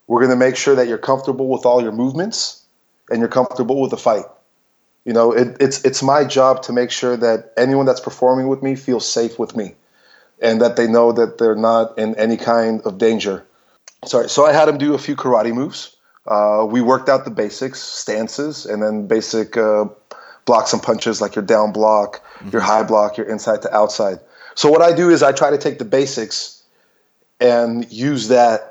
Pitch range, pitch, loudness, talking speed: 110-135 Hz, 120 Hz, -16 LUFS, 205 wpm